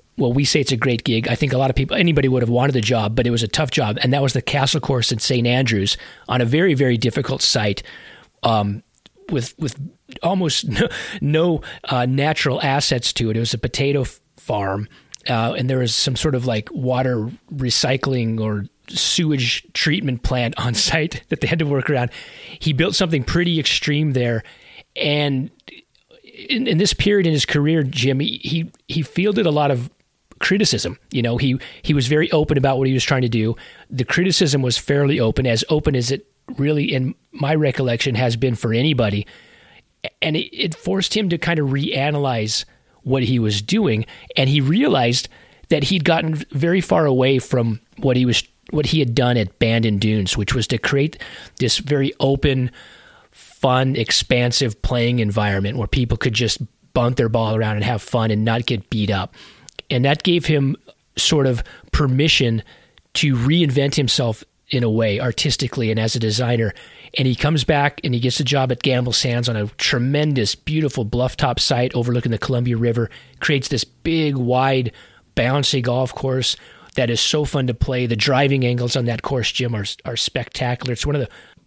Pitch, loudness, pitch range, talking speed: 130 Hz, -19 LUFS, 120-145 Hz, 190 wpm